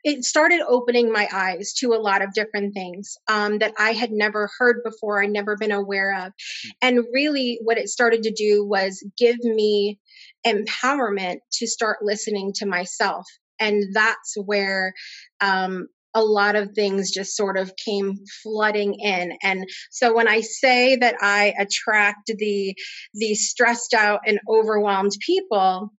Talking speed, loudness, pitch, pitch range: 155 wpm, -21 LUFS, 210 Hz, 200-230 Hz